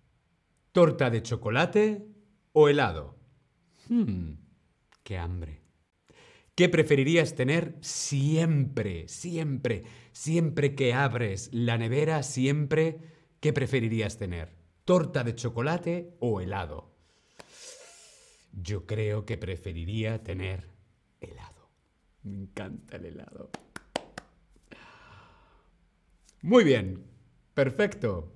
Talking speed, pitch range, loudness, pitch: 85 wpm, 100-155 Hz, -28 LUFS, 125 Hz